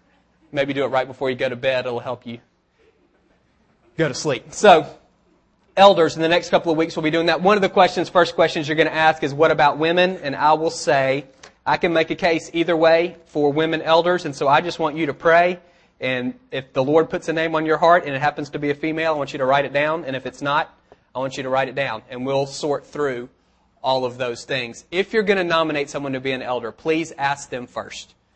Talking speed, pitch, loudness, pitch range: 255 wpm, 155 Hz, -20 LUFS, 135-165 Hz